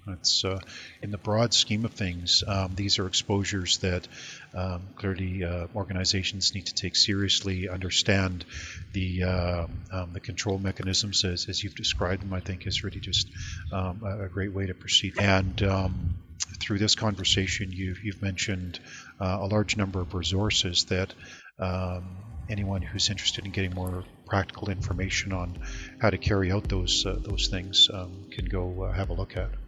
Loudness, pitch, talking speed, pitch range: -27 LUFS, 95 Hz, 170 wpm, 90-100 Hz